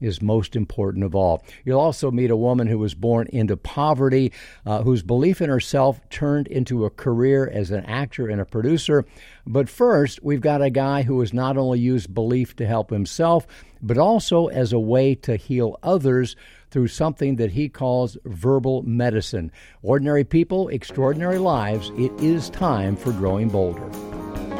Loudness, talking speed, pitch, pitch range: -21 LUFS, 170 wpm, 125 Hz, 110-140 Hz